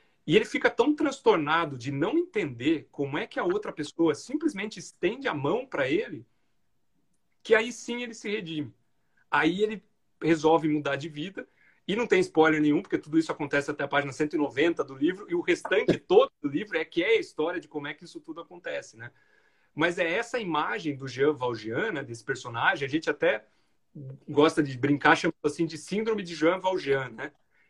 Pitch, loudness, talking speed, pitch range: 160 Hz, -27 LUFS, 195 wpm, 150-230 Hz